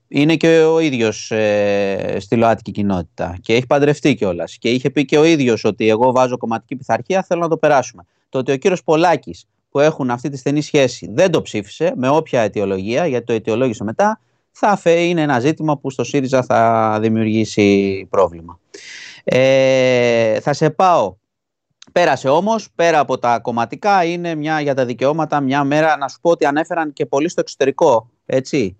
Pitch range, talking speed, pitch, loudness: 110-155 Hz, 180 wpm, 130 Hz, -16 LUFS